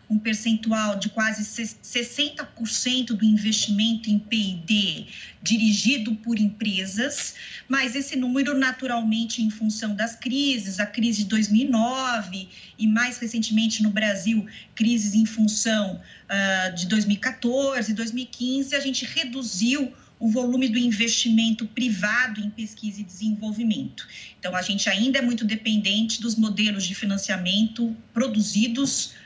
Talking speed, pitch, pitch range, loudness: 125 wpm, 220 Hz, 215-240 Hz, -24 LUFS